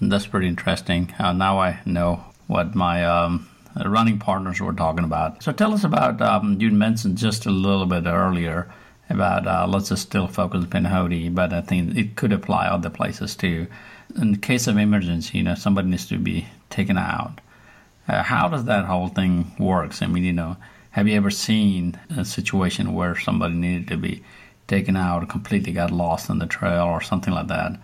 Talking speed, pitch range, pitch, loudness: 195 wpm, 85-100 Hz, 95 Hz, -22 LUFS